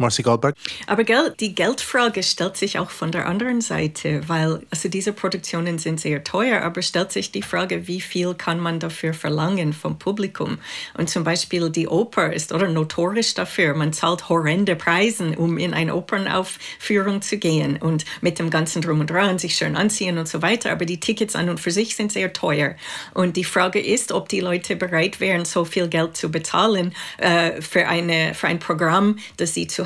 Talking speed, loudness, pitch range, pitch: 190 wpm, -21 LUFS, 165-195 Hz, 175 Hz